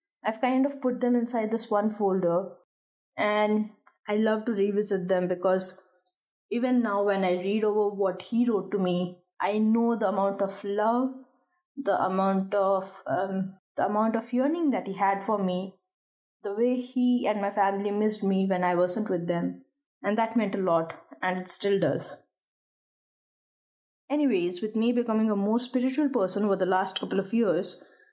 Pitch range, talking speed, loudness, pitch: 190-235 Hz, 175 wpm, -27 LUFS, 205 Hz